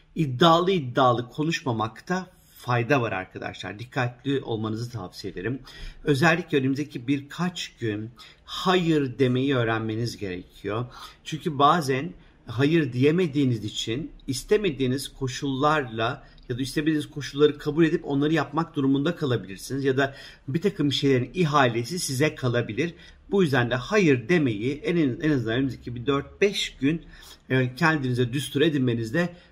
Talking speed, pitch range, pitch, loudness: 120 wpm, 125-155 Hz, 140 Hz, -25 LUFS